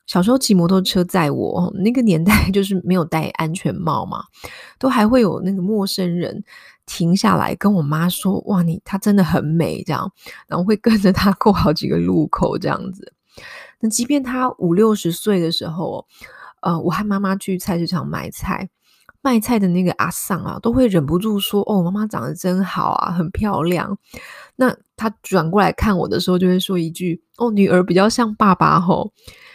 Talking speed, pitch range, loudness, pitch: 275 characters per minute, 175-215 Hz, -18 LUFS, 190 Hz